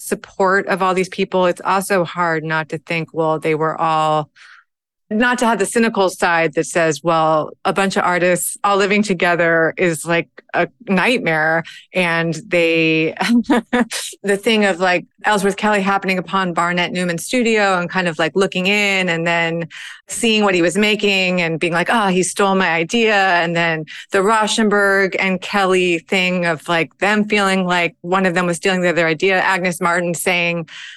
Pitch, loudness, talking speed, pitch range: 185 Hz, -16 LUFS, 180 wpm, 170-195 Hz